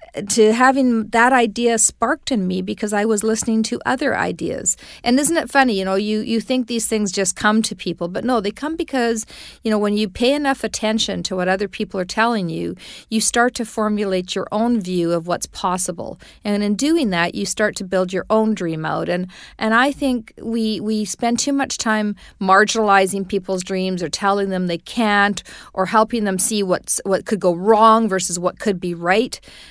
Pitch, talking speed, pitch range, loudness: 215 Hz, 210 wpm, 190-230 Hz, -19 LUFS